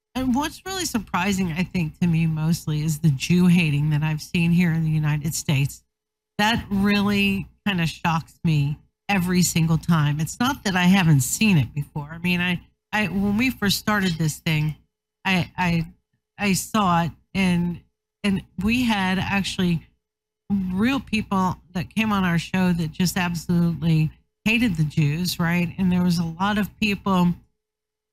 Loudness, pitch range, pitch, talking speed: -22 LUFS, 160-200 Hz, 180 Hz, 170 wpm